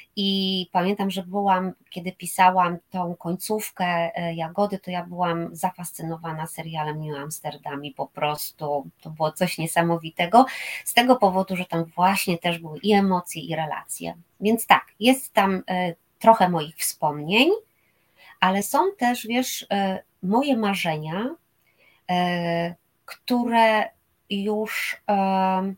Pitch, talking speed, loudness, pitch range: 185 Hz, 125 wpm, -23 LUFS, 170-200 Hz